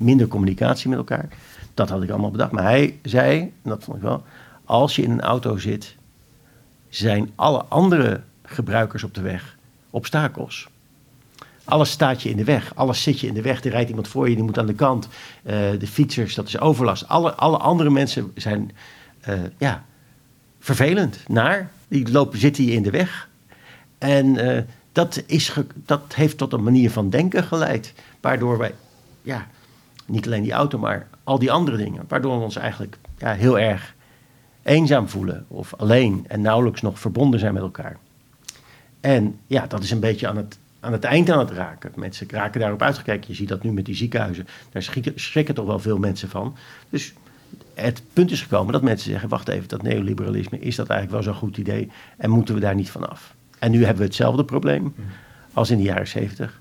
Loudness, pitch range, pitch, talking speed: -21 LUFS, 105-135 Hz, 120 Hz, 195 wpm